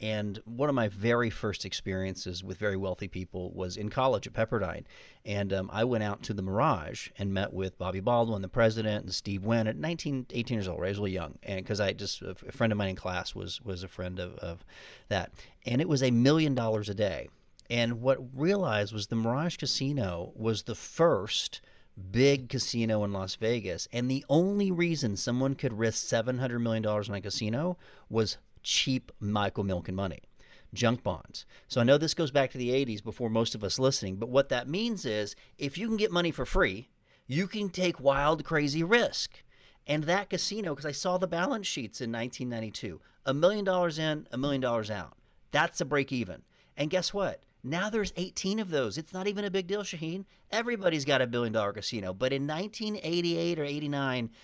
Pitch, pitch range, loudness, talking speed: 120 Hz, 100-150 Hz, -31 LUFS, 205 wpm